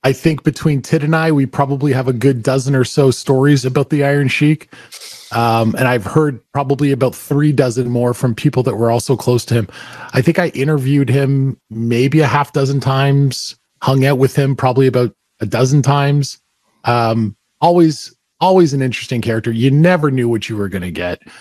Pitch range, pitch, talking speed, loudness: 120-145 Hz, 135 Hz, 195 wpm, -15 LUFS